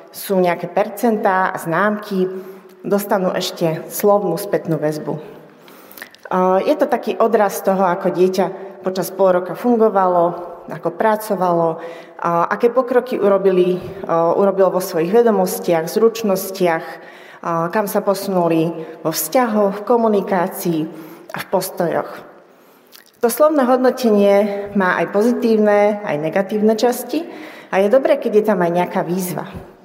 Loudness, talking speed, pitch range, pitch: -17 LUFS, 120 wpm, 175-215 Hz, 190 Hz